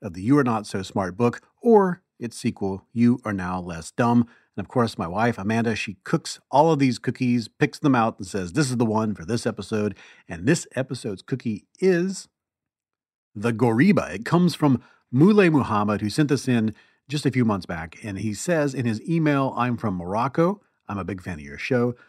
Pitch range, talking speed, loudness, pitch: 105-140 Hz, 210 wpm, -23 LUFS, 120 Hz